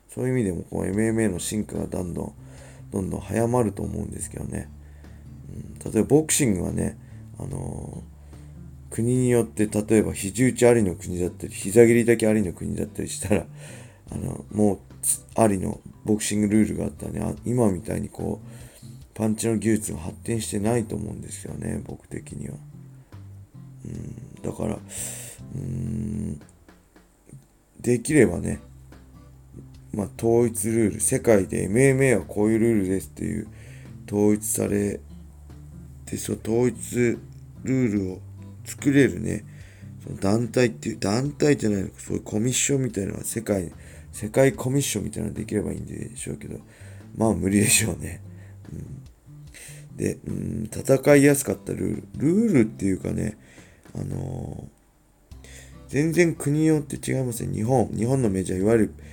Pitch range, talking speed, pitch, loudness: 95-120 Hz, 325 characters per minute, 105 Hz, -24 LUFS